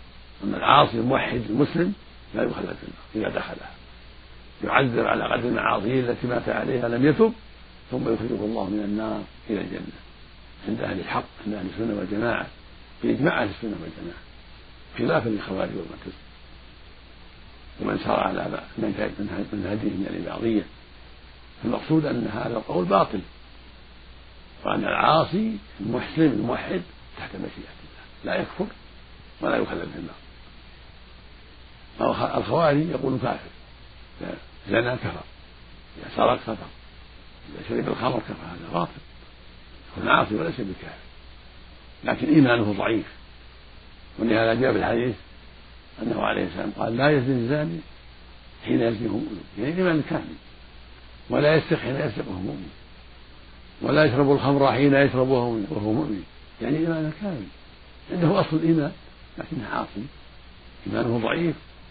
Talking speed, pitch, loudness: 125 wpm, 85 Hz, -25 LUFS